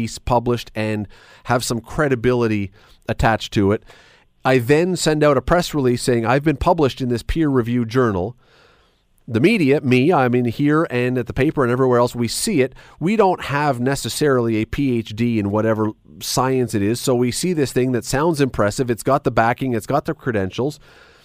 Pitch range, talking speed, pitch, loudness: 115-140 Hz, 190 wpm, 125 Hz, -19 LUFS